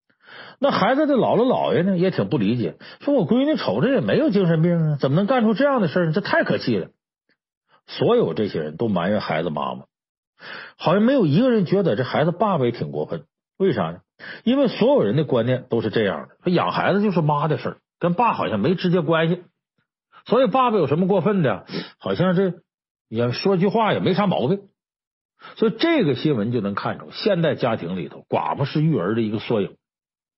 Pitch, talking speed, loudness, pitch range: 185 Hz, 305 characters per minute, -21 LUFS, 155-215 Hz